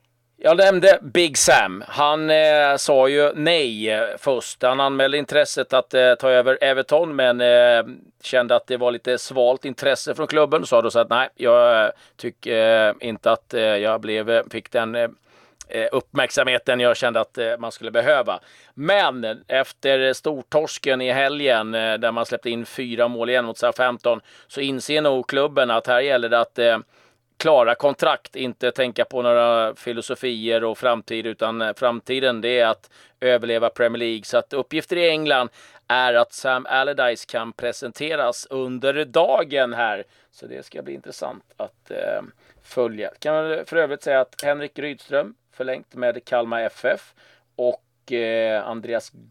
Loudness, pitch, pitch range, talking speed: -20 LUFS, 125 Hz, 115-140 Hz, 160 wpm